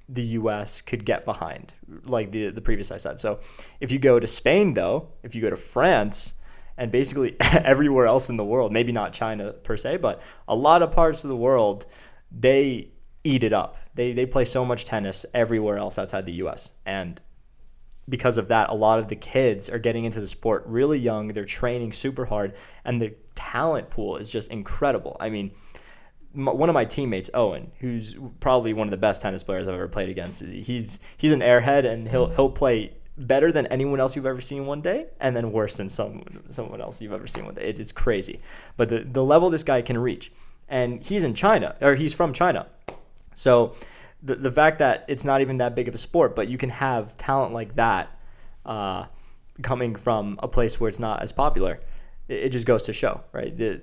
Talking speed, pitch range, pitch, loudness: 210 wpm, 110-135 Hz, 125 Hz, -24 LUFS